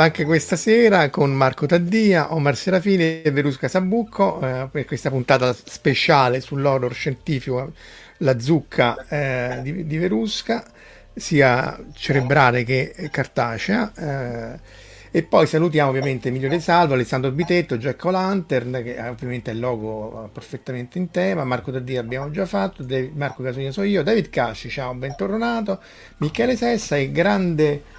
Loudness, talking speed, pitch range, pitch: -21 LUFS, 140 wpm, 130-180 Hz, 145 Hz